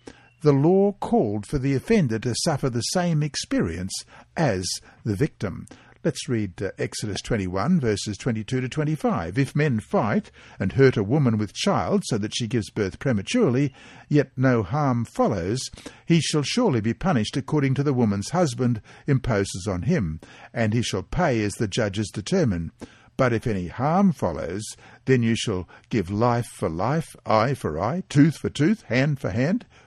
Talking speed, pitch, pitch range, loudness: 170 wpm, 120 Hz, 105-145 Hz, -24 LUFS